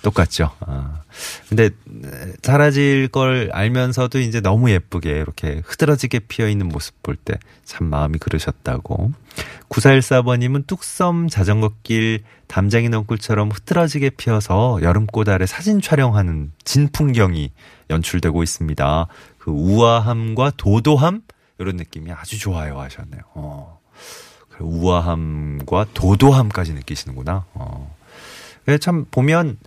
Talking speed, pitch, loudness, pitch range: 275 characters per minute, 105 Hz, -18 LUFS, 85-130 Hz